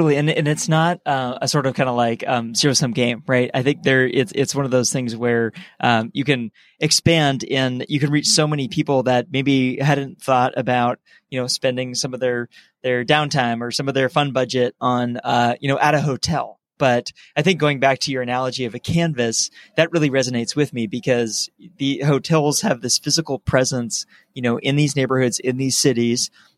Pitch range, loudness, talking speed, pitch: 125-145 Hz, -19 LUFS, 210 wpm, 130 Hz